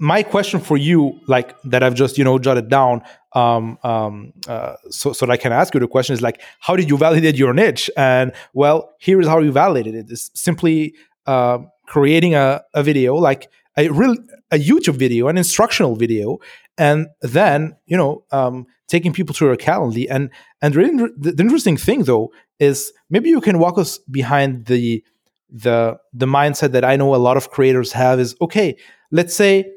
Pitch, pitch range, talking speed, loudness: 140 Hz, 125-170 Hz, 195 wpm, -16 LUFS